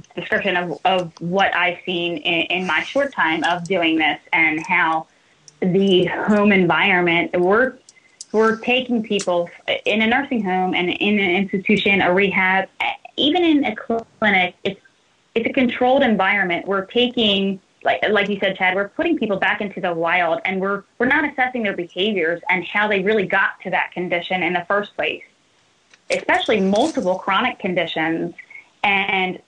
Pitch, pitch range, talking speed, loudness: 195 Hz, 180-220 Hz, 165 wpm, -19 LUFS